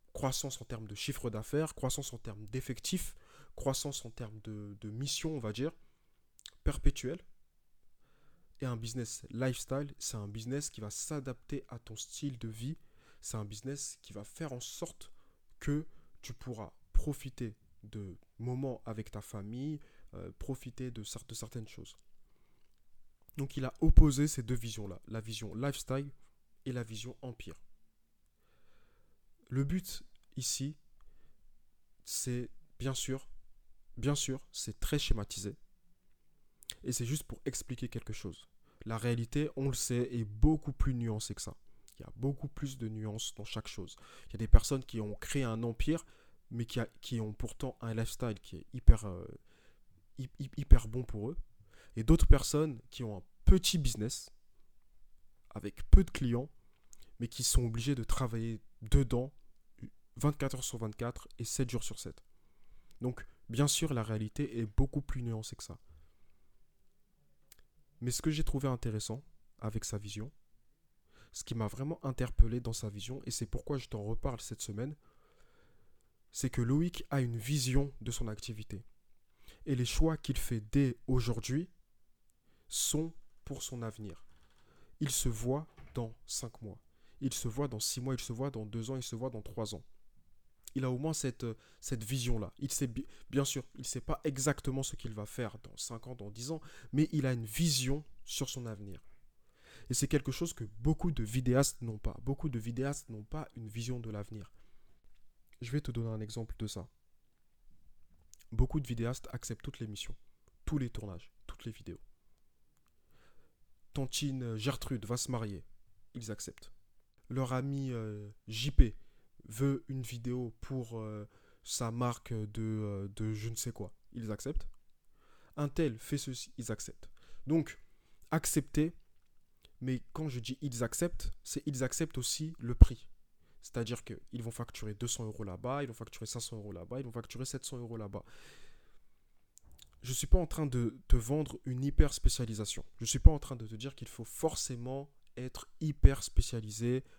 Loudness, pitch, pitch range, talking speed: -37 LUFS, 120 Hz, 110-135 Hz, 170 wpm